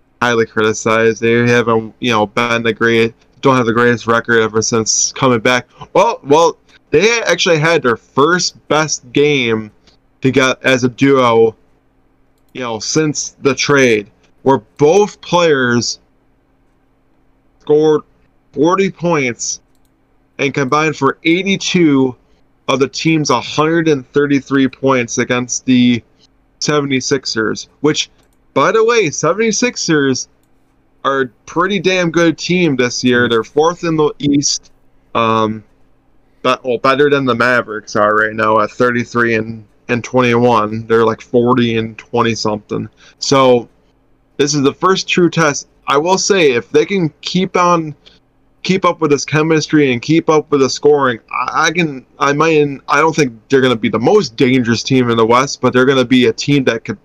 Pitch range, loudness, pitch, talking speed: 115-150 Hz, -13 LUFS, 130 Hz, 160 wpm